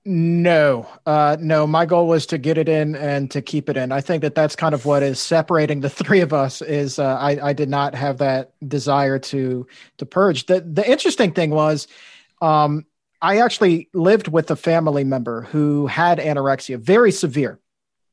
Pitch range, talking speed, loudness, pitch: 140-165 Hz, 190 wpm, -18 LUFS, 150 Hz